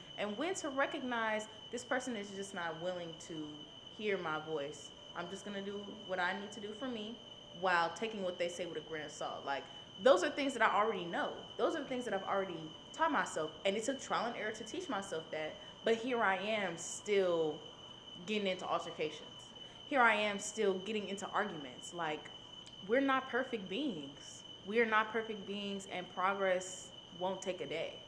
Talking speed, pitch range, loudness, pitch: 195 wpm, 180-225 Hz, -37 LUFS, 200 Hz